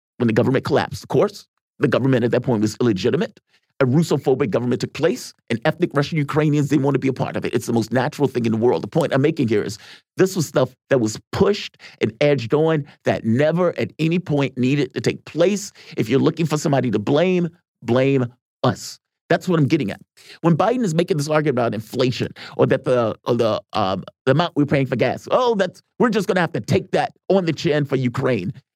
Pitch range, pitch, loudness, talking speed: 130-170 Hz, 145 Hz, -20 LUFS, 225 wpm